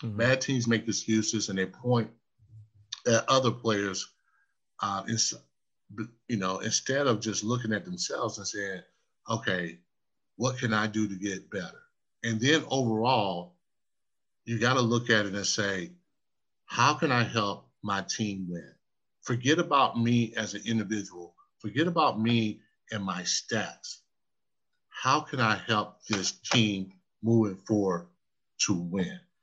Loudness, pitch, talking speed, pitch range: -29 LUFS, 110 Hz, 145 wpm, 100-120 Hz